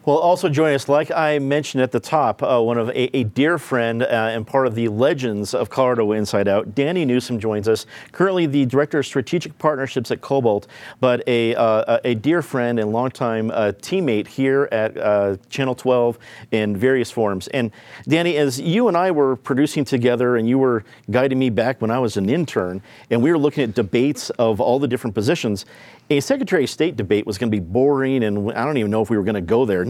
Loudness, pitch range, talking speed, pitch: -19 LUFS, 110-140 Hz, 220 wpm, 125 Hz